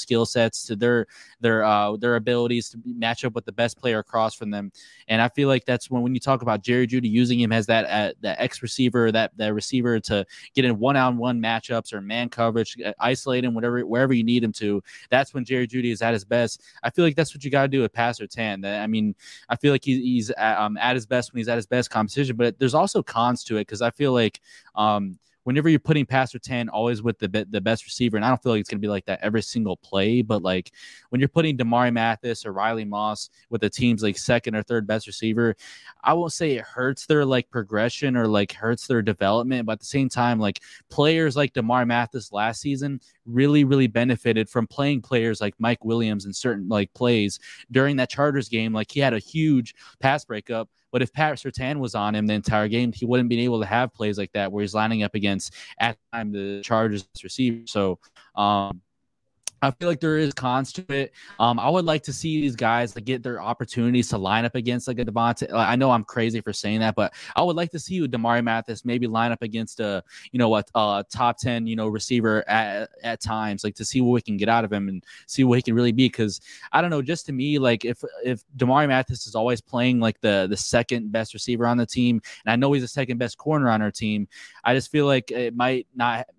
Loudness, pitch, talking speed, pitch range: -23 LUFS, 120 Hz, 245 wpm, 110-125 Hz